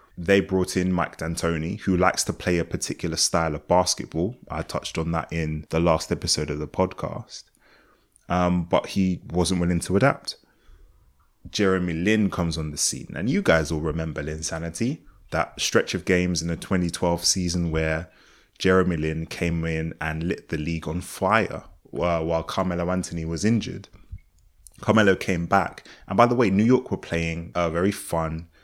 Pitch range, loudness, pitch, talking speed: 80-95 Hz, -24 LUFS, 85 Hz, 175 wpm